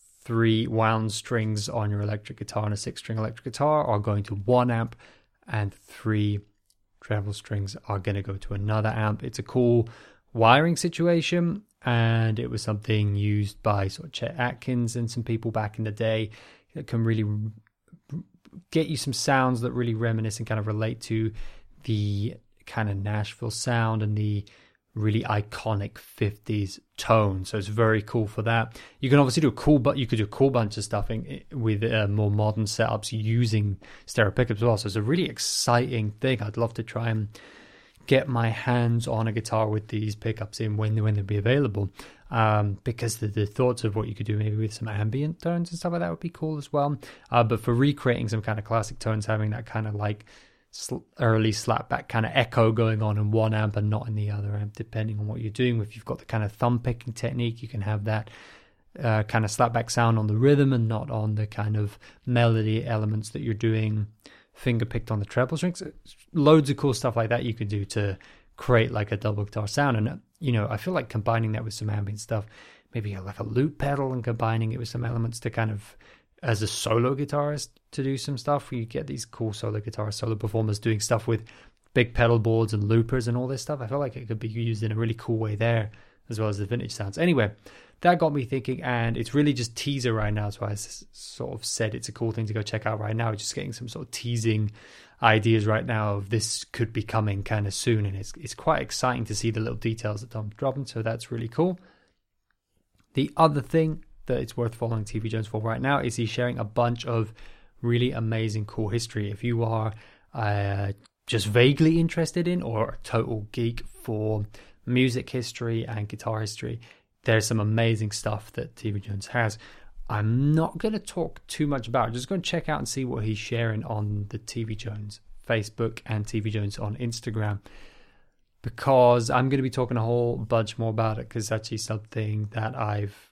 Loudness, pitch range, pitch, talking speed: -27 LUFS, 105-120 Hz, 115 Hz, 215 wpm